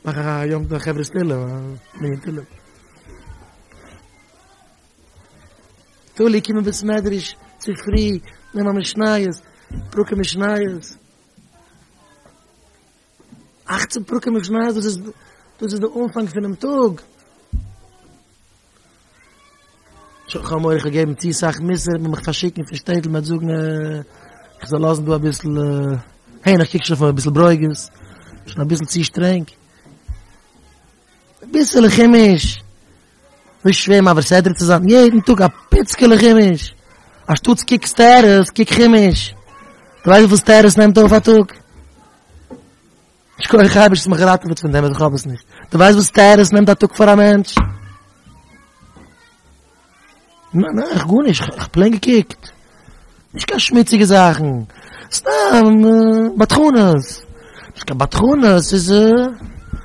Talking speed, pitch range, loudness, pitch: 125 wpm, 145-215 Hz, -13 LUFS, 180 Hz